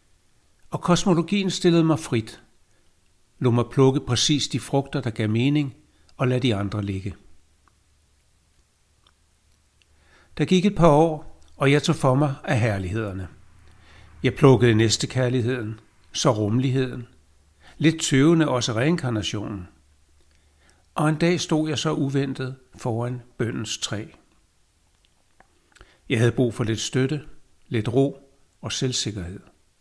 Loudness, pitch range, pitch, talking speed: -22 LUFS, 90-140 Hz, 120 Hz, 125 wpm